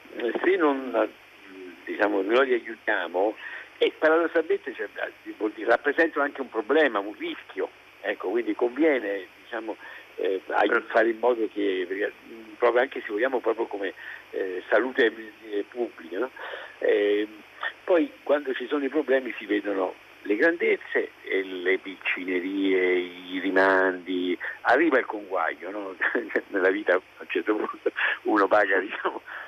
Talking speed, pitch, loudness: 130 wpm, 370 Hz, -26 LUFS